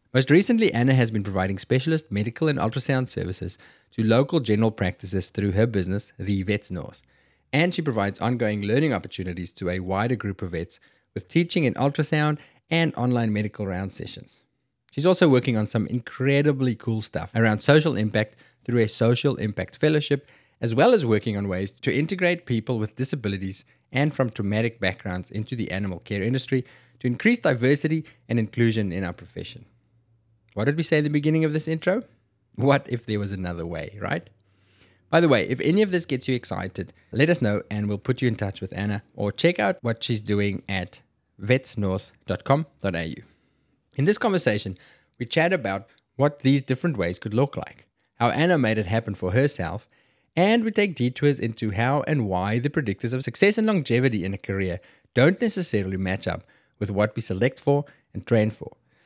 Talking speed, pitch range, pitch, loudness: 185 wpm, 100-140 Hz, 115 Hz, -24 LUFS